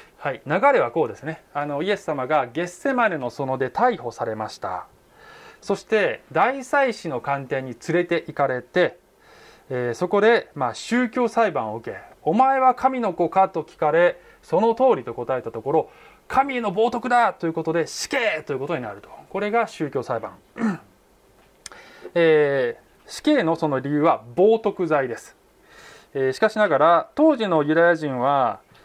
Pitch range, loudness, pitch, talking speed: 155-250 Hz, -22 LUFS, 190 Hz, 305 characters per minute